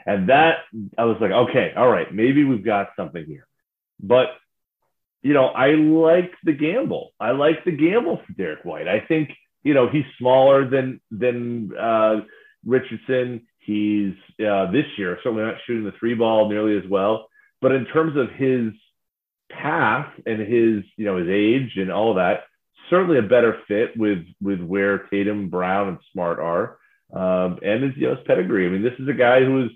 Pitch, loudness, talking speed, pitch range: 115 Hz, -20 LUFS, 190 wpm, 105-130 Hz